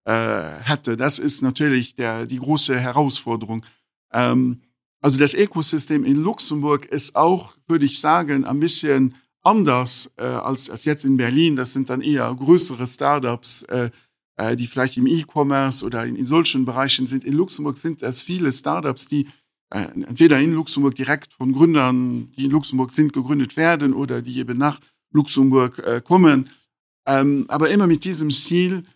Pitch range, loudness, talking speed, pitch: 125-150 Hz, -19 LUFS, 160 wpm, 140 Hz